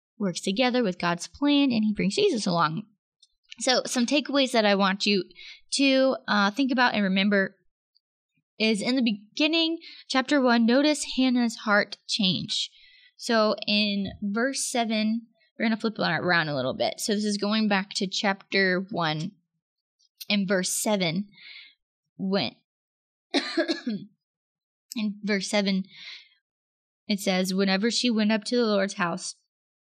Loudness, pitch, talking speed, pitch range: -25 LUFS, 210 Hz, 140 wpm, 195-245 Hz